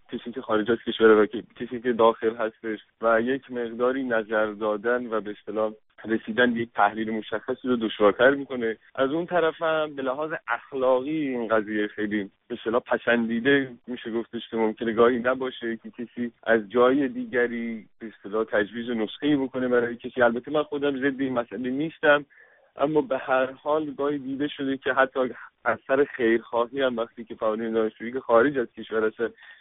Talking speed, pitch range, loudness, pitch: 170 wpm, 110-130 Hz, -25 LUFS, 120 Hz